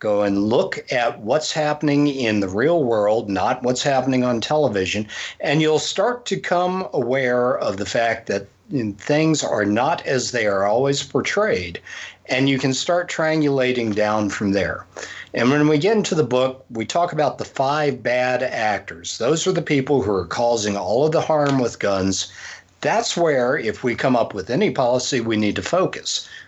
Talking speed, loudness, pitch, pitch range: 185 wpm, -20 LUFS, 130 Hz, 115-150 Hz